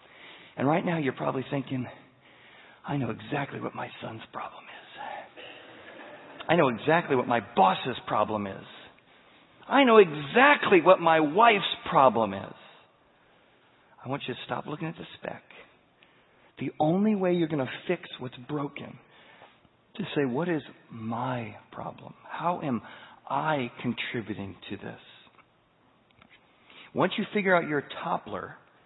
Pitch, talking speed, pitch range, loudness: 140 Hz, 140 wpm, 125-175 Hz, -26 LUFS